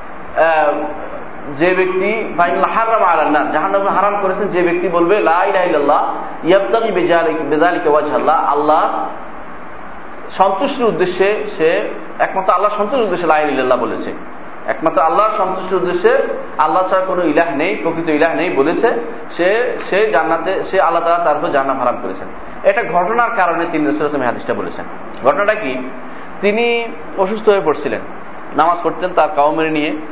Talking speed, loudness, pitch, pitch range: 130 wpm, -15 LUFS, 175 Hz, 155-200 Hz